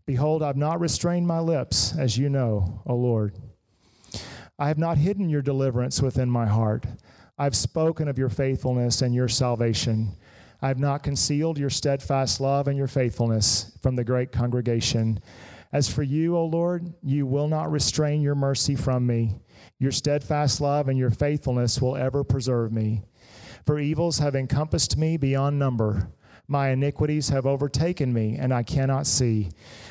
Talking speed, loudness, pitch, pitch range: 160 wpm, -24 LUFS, 135 Hz, 120-145 Hz